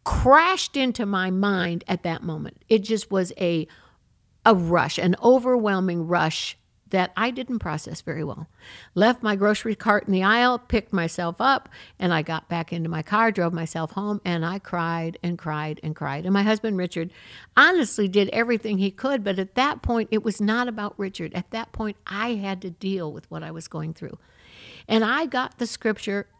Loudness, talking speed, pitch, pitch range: -23 LUFS, 195 wpm, 195 Hz, 170-225 Hz